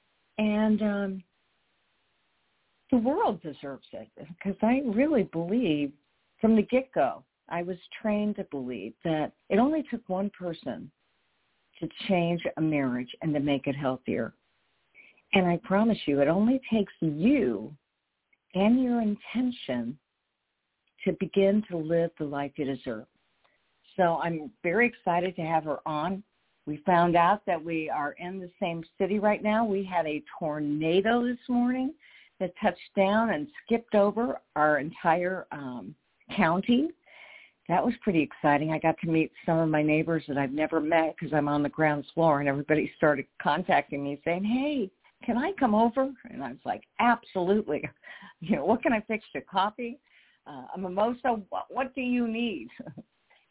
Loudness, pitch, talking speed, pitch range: -28 LUFS, 185 Hz, 160 wpm, 155-225 Hz